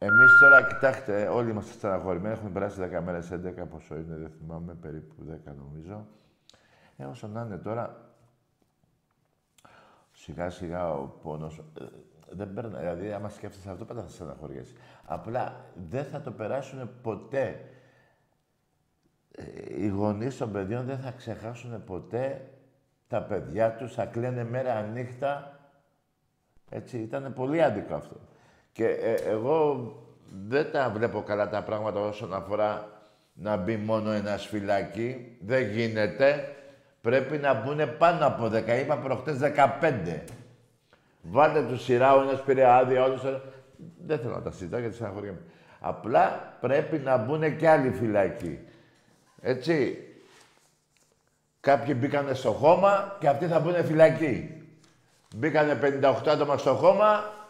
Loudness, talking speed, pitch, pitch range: -26 LUFS, 130 wpm, 125 Hz, 105-140 Hz